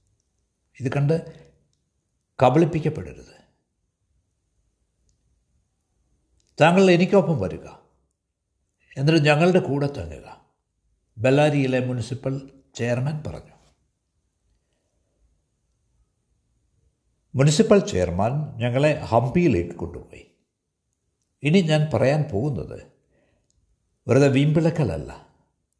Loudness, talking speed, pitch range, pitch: -21 LUFS, 60 wpm, 90-150 Hz, 125 Hz